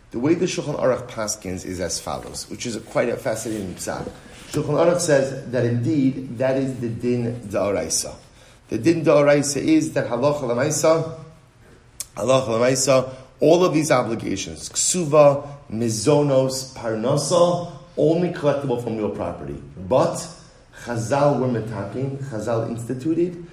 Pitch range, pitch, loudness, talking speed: 115-150 Hz, 130 Hz, -21 LUFS, 135 wpm